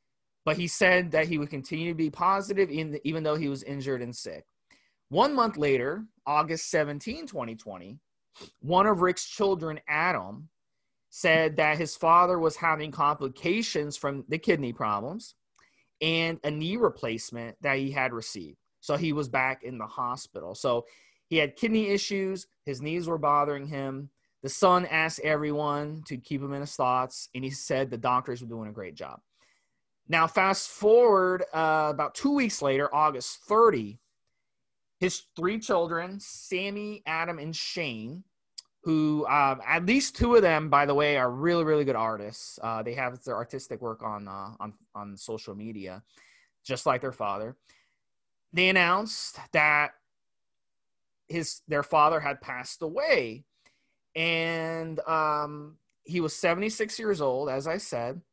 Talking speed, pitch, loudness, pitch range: 155 wpm, 150 Hz, -27 LUFS, 135-175 Hz